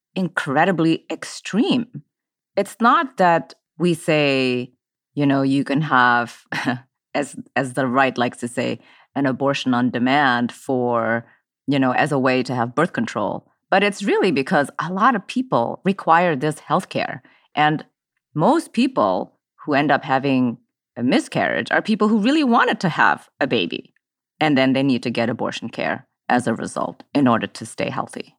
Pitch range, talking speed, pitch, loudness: 125-180 Hz, 165 wpm, 140 Hz, -20 LUFS